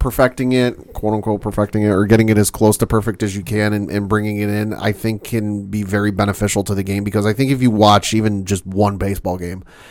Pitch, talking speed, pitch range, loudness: 105 Hz, 250 wpm, 100-110 Hz, -17 LUFS